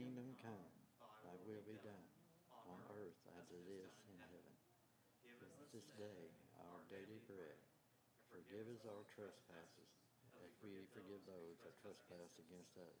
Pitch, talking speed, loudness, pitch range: 100 Hz, 150 wpm, -61 LUFS, 90-110 Hz